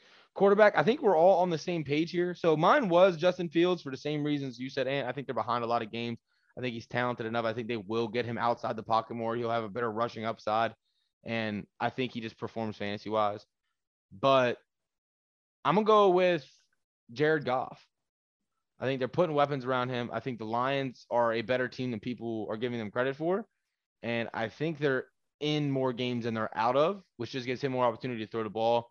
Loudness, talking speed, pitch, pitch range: -30 LUFS, 225 wpm, 125 Hz, 115-150 Hz